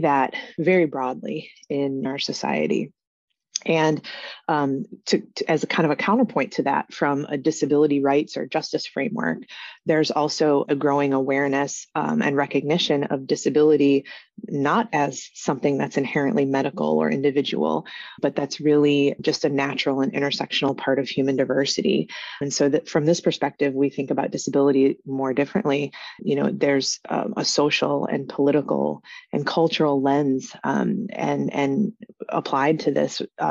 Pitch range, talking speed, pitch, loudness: 140-155 Hz, 150 wpm, 140 Hz, -22 LUFS